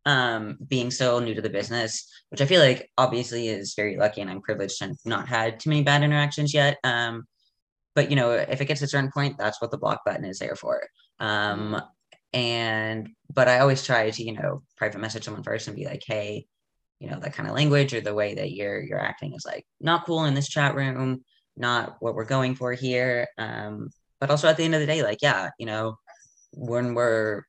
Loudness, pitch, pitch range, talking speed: -25 LUFS, 125 Hz, 110-145 Hz, 225 wpm